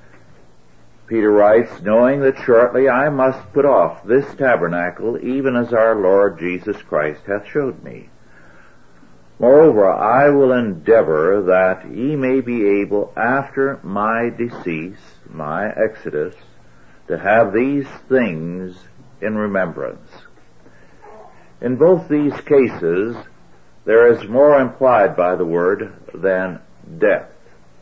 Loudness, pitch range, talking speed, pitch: -16 LUFS, 95-135 Hz, 115 wpm, 115 Hz